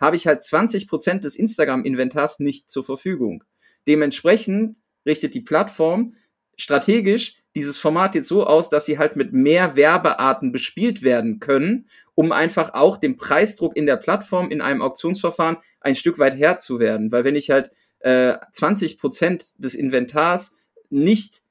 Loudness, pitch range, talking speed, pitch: -19 LUFS, 140-205 Hz, 145 wpm, 155 Hz